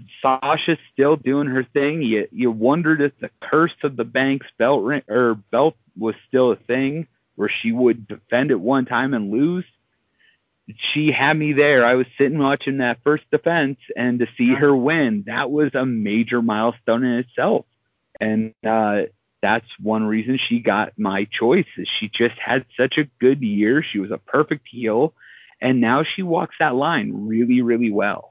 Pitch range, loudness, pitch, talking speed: 115-145 Hz, -20 LUFS, 125 Hz, 175 wpm